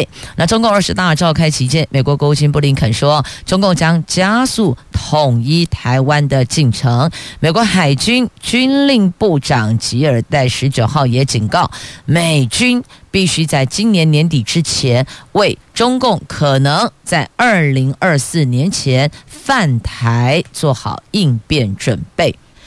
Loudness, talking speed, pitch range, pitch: -13 LUFS, 210 characters per minute, 130-175 Hz, 150 Hz